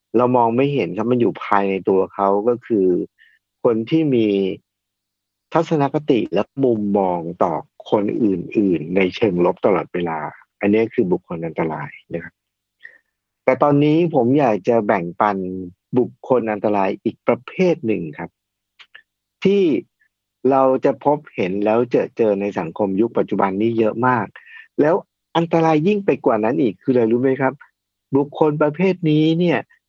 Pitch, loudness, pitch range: 125 Hz, -19 LUFS, 100-155 Hz